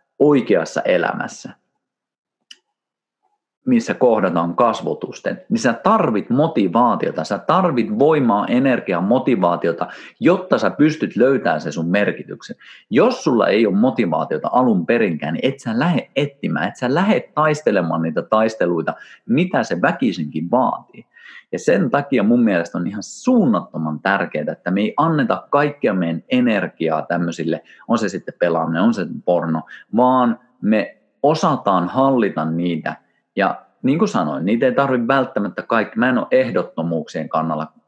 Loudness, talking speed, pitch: -18 LUFS, 140 wpm, 130 Hz